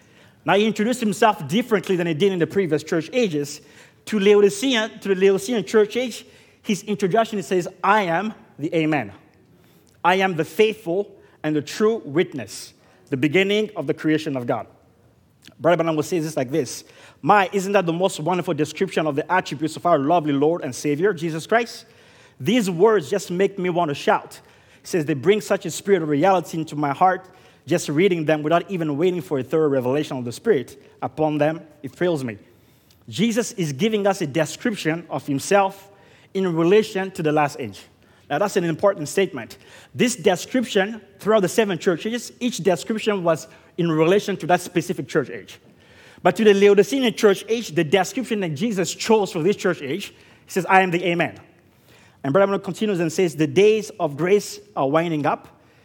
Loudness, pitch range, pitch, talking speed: -21 LUFS, 155-200 Hz, 180 Hz, 185 wpm